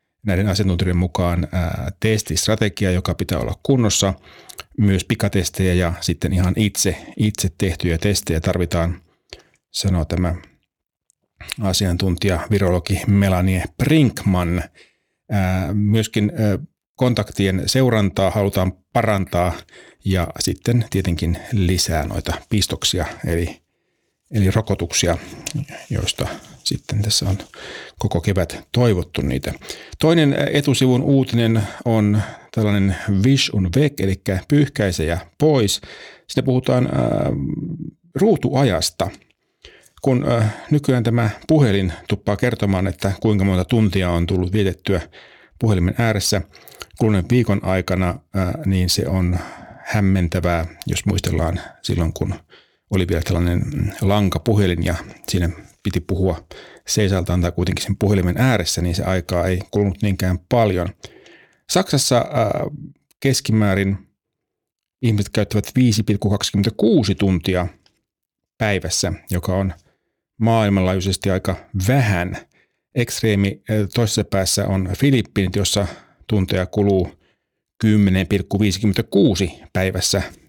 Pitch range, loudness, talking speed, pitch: 90-110 Hz, -19 LUFS, 100 wpm, 100 Hz